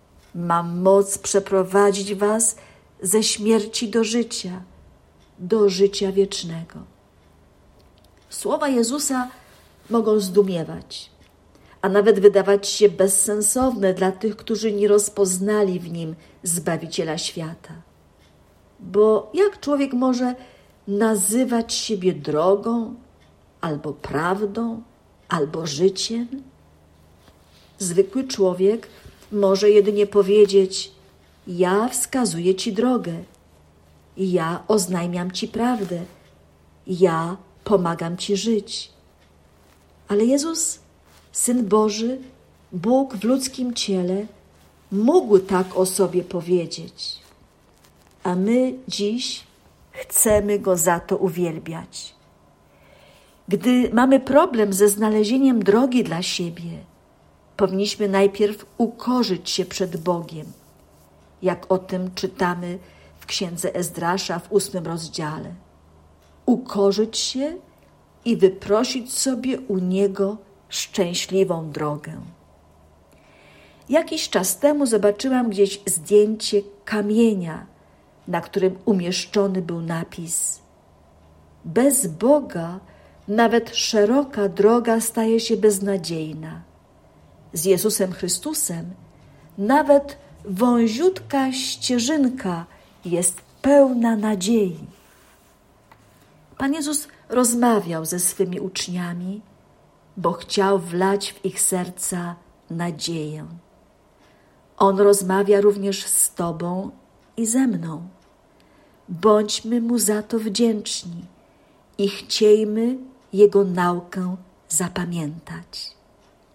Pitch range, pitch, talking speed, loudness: 175-225 Hz, 195 Hz, 90 wpm, -21 LUFS